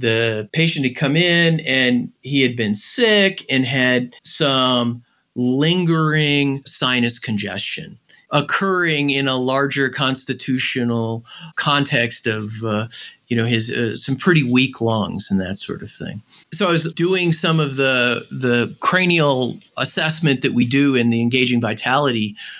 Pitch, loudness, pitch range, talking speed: 130 Hz, -18 LUFS, 120-155 Hz, 145 wpm